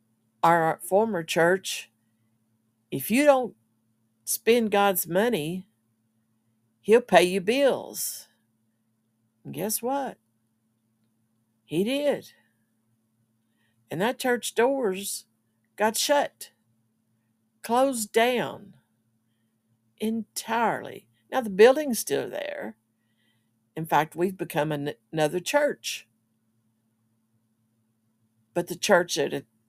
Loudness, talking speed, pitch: -25 LUFS, 90 wpm, 115 Hz